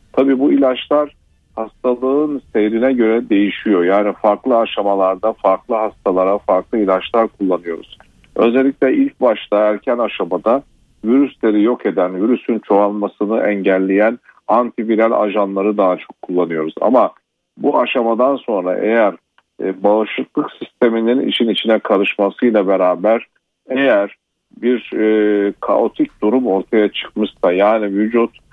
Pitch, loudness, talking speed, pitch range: 110 Hz, -16 LUFS, 105 wpm, 100-120 Hz